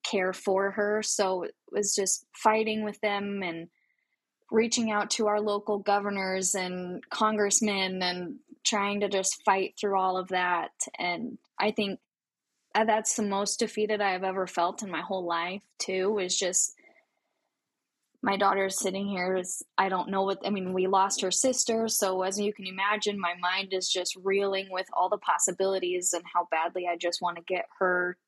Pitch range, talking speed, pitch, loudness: 185-210 Hz, 175 wpm, 195 Hz, -28 LUFS